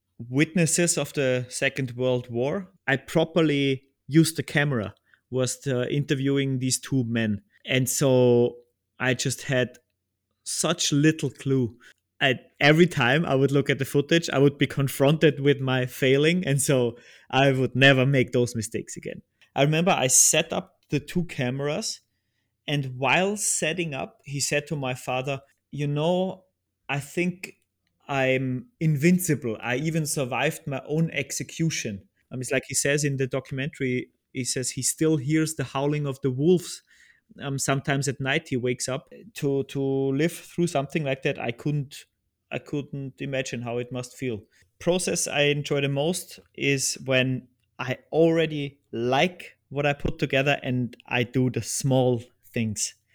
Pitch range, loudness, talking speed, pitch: 125-150 Hz, -25 LUFS, 155 wpm, 135 Hz